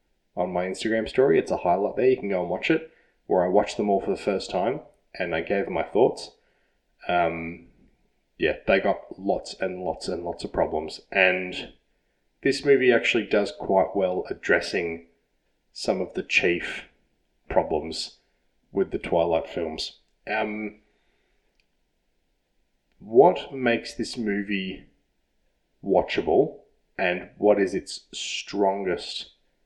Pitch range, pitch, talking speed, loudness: 85-120 Hz, 100 Hz, 140 wpm, -25 LUFS